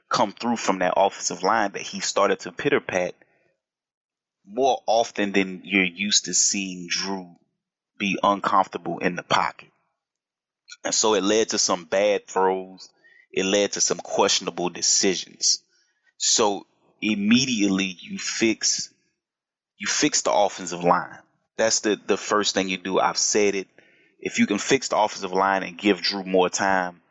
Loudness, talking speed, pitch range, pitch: -22 LUFS, 155 wpm, 95-105 Hz, 95 Hz